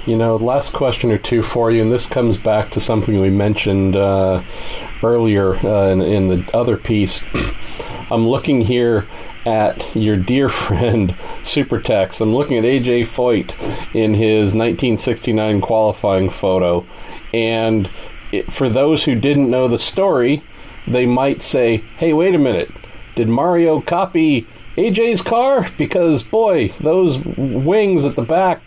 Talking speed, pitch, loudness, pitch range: 145 wpm, 115 Hz, -16 LUFS, 105-135 Hz